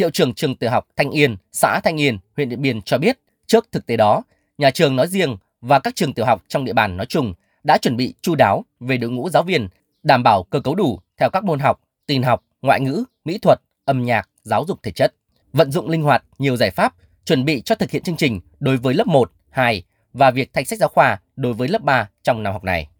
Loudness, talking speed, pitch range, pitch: -19 LUFS, 255 wpm, 115-155 Hz, 135 Hz